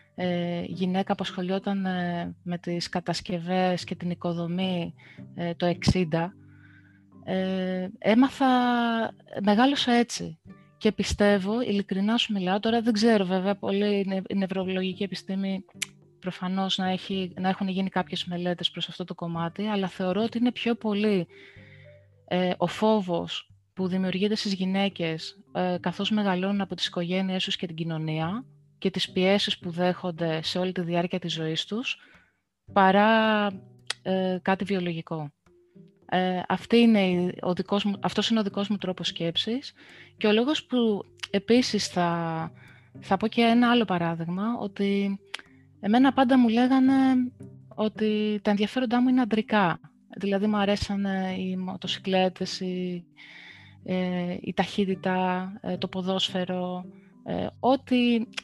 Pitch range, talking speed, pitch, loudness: 175-210 Hz, 140 wpm, 190 Hz, -26 LUFS